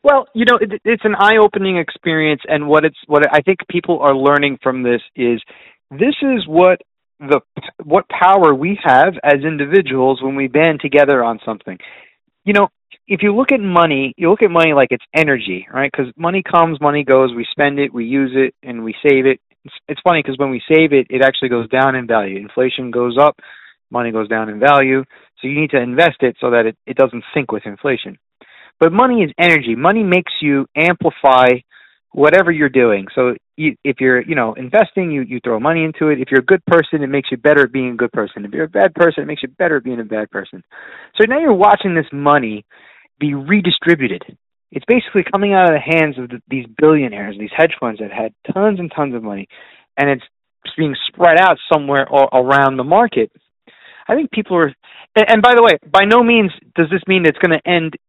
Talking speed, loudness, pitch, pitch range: 220 wpm, -14 LUFS, 145 Hz, 130-175 Hz